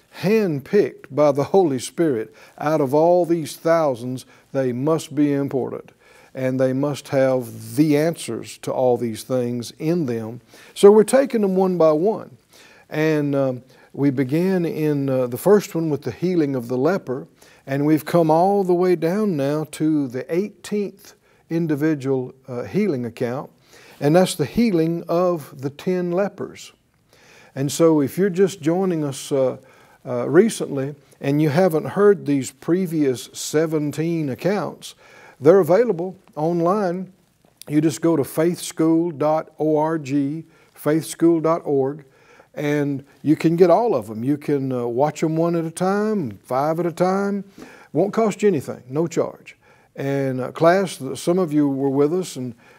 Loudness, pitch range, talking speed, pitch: -20 LUFS, 135-175 Hz, 155 wpm, 155 Hz